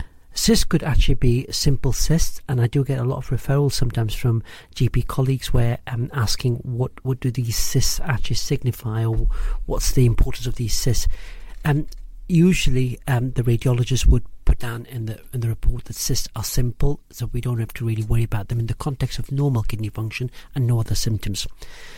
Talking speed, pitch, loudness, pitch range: 200 wpm, 125 Hz, -23 LUFS, 115-135 Hz